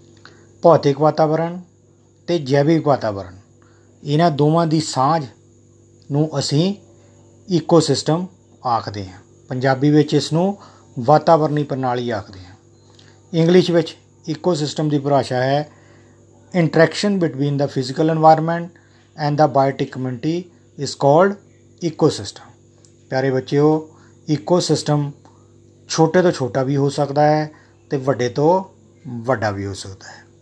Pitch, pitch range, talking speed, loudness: 140 Hz, 115-155 Hz, 115 wpm, -18 LUFS